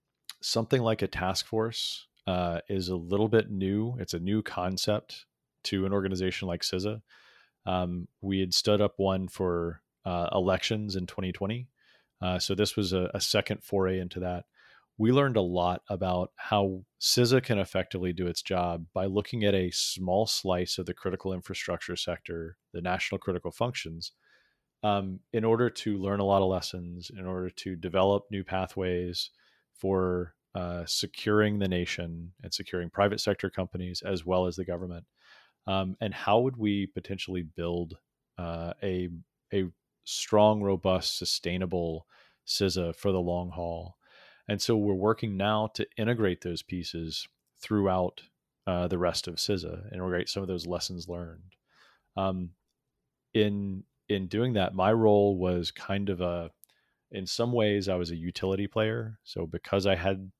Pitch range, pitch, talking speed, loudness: 90-105 Hz, 95 Hz, 160 wpm, -30 LUFS